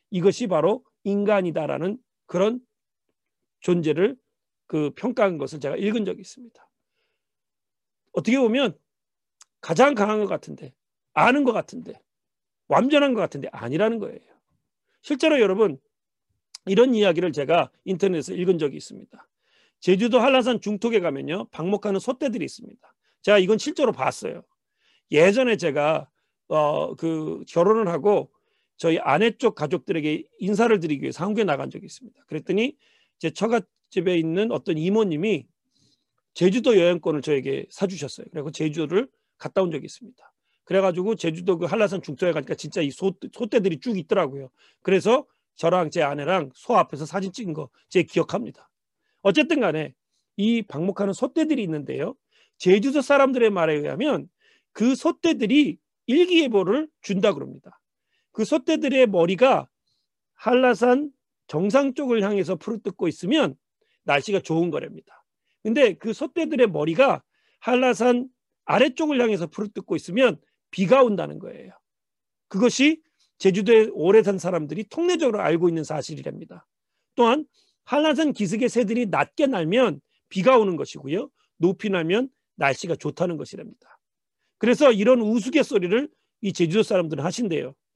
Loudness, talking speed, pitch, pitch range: -22 LUFS, 325 characters per minute, 210 Hz, 175-250 Hz